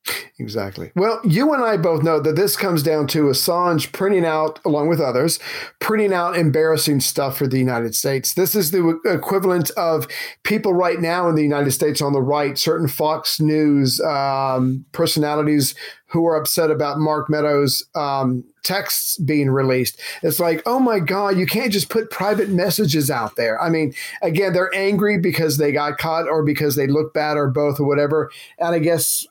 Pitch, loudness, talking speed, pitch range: 155 Hz, -19 LUFS, 185 wpm, 145-185 Hz